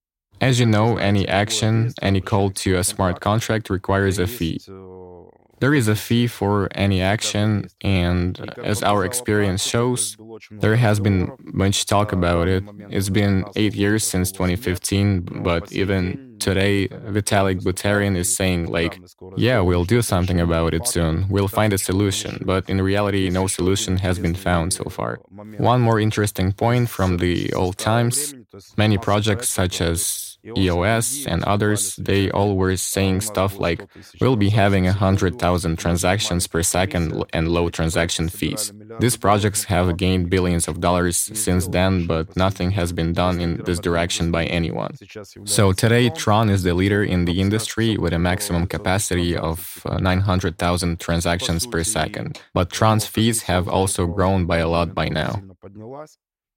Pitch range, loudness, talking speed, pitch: 90-105 Hz, -20 LUFS, 160 wpm, 95 Hz